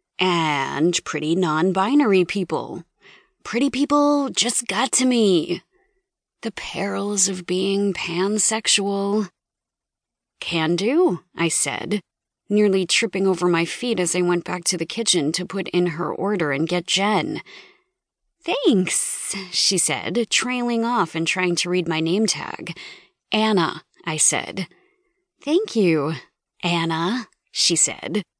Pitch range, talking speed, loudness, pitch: 170-225 Hz, 125 wpm, -21 LUFS, 190 Hz